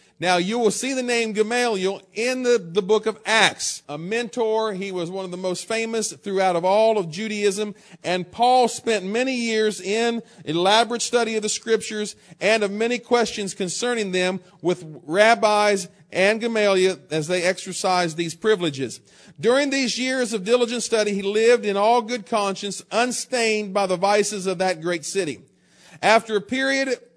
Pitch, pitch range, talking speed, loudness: 210 Hz, 185-230 Hz, 170 wpm, -22 LUFS